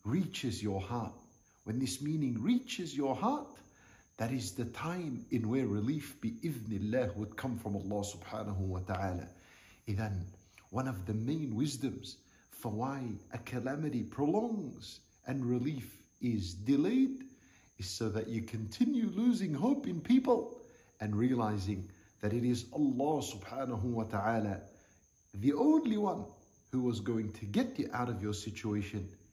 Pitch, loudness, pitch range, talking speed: 120 Hz, -35 LUFS, 105-145 Hz, 145 wpm